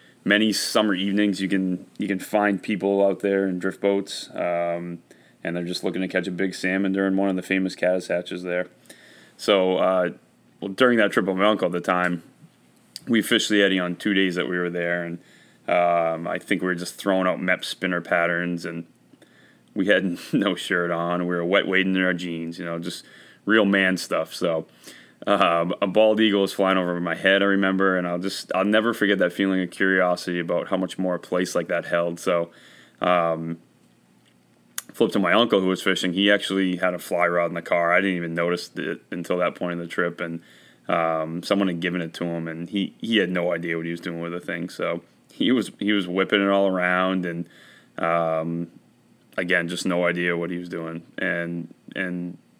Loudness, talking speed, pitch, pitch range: -23 LUFS, 215 wpm, 90 Hz, 85-95 Hz